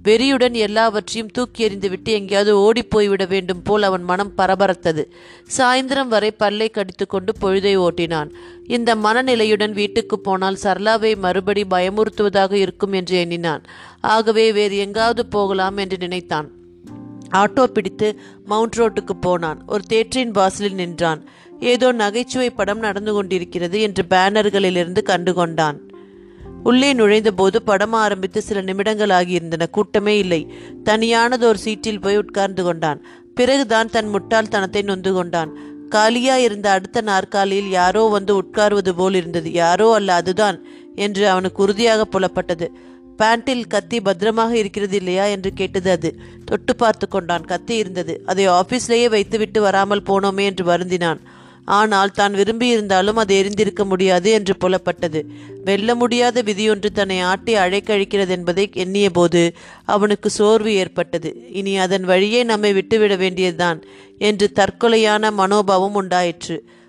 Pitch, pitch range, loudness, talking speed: 200 Hz, 185-220 Hz, -17 LUFS, 125 wpm